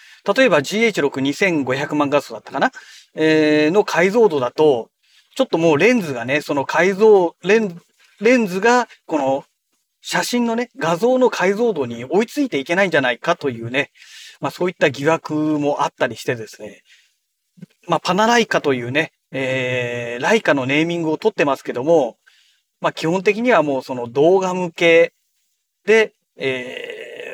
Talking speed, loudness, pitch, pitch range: 310 characters per minute, -18 LUFS, 170 Hz, 145-220 Hz